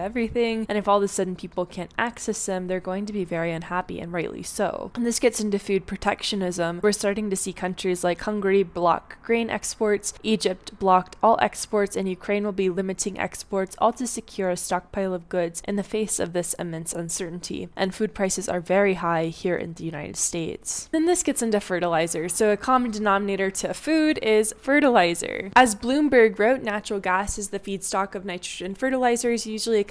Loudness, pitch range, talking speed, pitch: -24 LUFS, 185-220 Hz, 195 wpm, 200 Hz